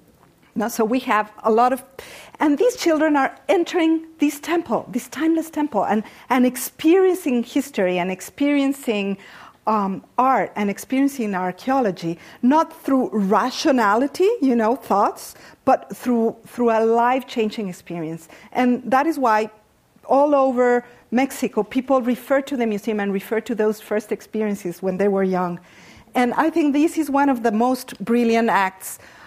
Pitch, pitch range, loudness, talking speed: 240 Hz, 210-275 Hz, -20 LUFS, 150 wpm